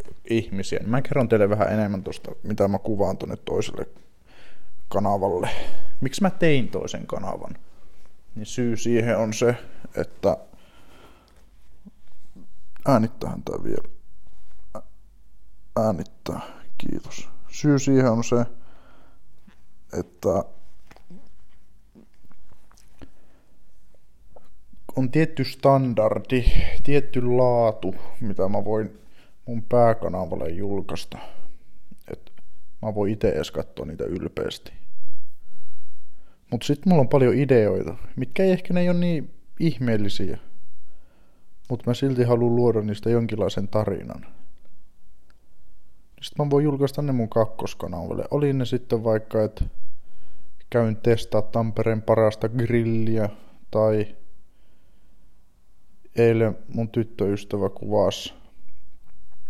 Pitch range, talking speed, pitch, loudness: 95-125 Hz, 100 wpm, 110 Hz, -24 LUFS